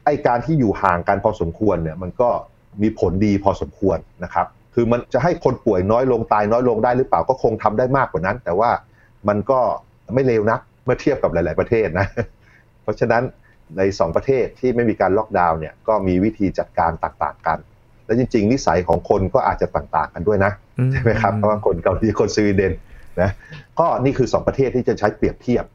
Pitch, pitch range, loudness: 105 Hz, 95-120 Hz, -19 LUFS